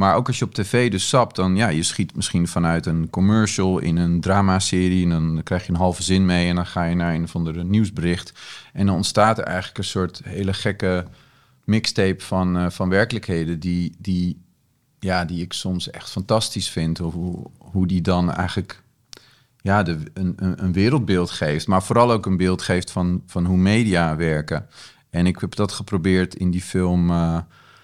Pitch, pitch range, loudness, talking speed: 90 Hz, 85-100 Hz, -21 LUFS, 195 wpm